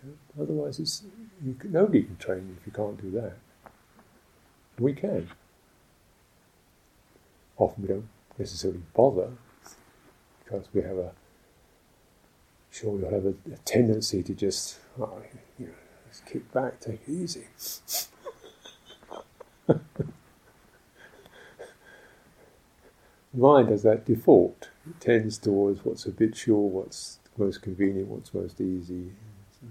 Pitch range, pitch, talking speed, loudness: 95-135 Hz, 105 Hz, 115 wpm, -27 LUFS